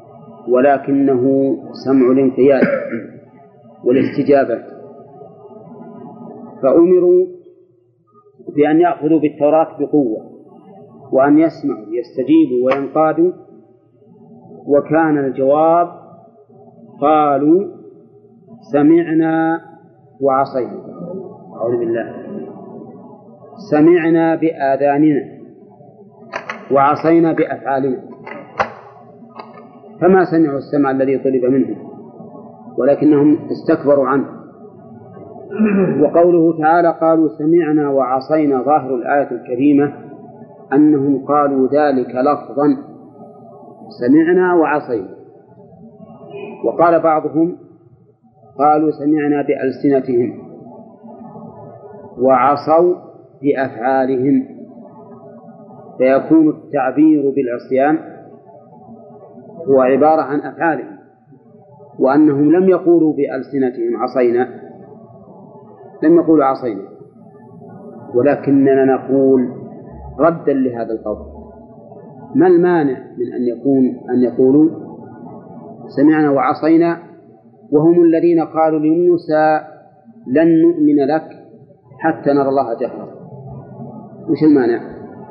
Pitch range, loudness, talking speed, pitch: 135-175 Hz, -14 LUFS, 70 wpm, 155 Hz